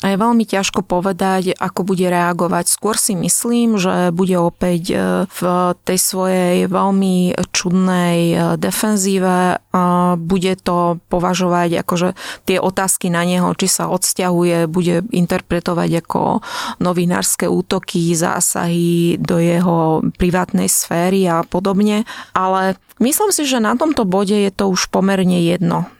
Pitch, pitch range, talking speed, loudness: 180 Hz, 175-195 Hz, 130 wpm, -16 LUFS